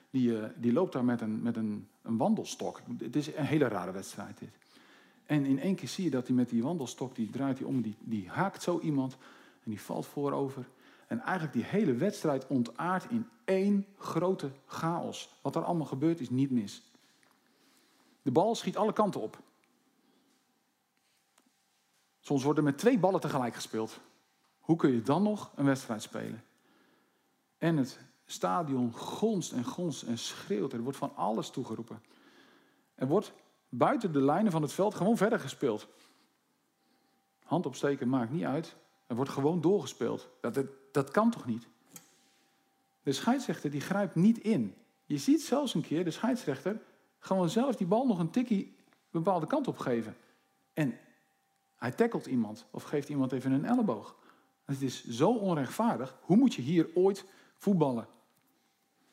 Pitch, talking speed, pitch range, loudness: 155 Hz, 165 wpm, 130-205 Hz, -32 LUFS